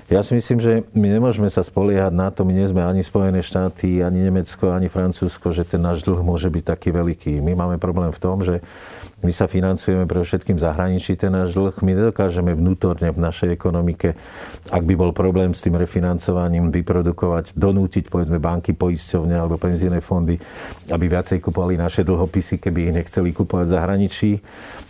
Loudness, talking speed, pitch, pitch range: -20 LUFS, 180 wpm, 90 Hz, 85-95 Hz